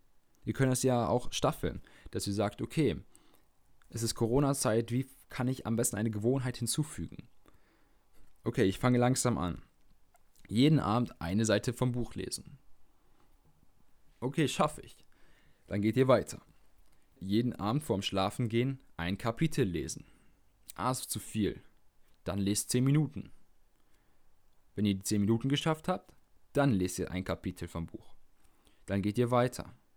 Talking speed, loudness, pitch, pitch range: 150 wpm, -32 LUFS, 110 Hz, 95-125 Hz